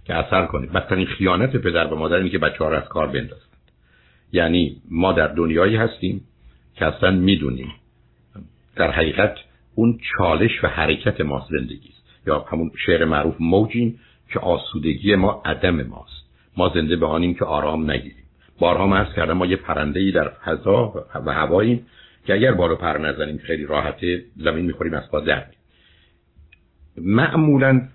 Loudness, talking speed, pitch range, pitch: -20 LUFS, 155 wpm, 75-95 Hz, 85 Hz